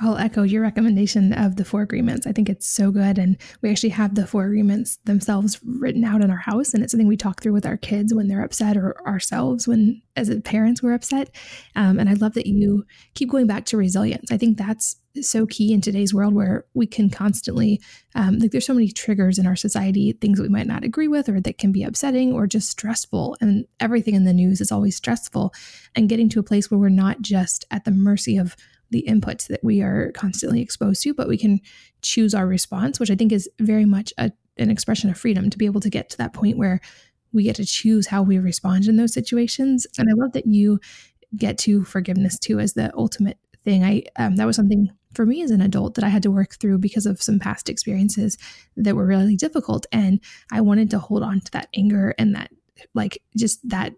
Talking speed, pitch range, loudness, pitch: 230 wpm, 200-225 Hz, -20 LUFS, 210 Hz